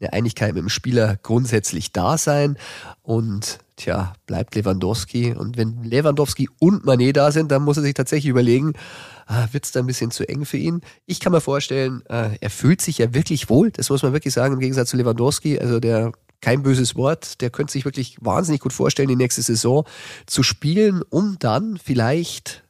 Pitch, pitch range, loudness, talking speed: 130 Hz, 115-145 Hz, -20 LUFS, 195 wpm